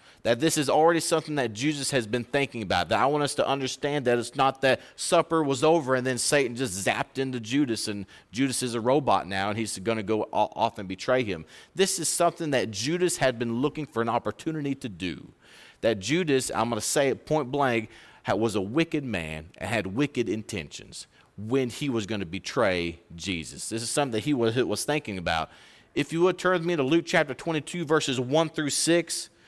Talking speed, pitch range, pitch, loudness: 215 wpm, 110-150 Hz, 130 Hz, -26 LUFS